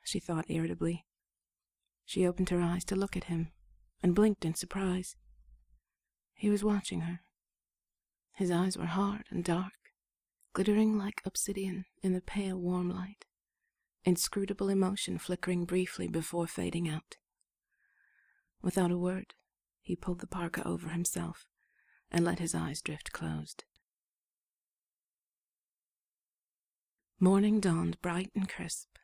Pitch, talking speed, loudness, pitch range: 180 Hz, 125 wpm, -33 LUFS, 165-195 Hz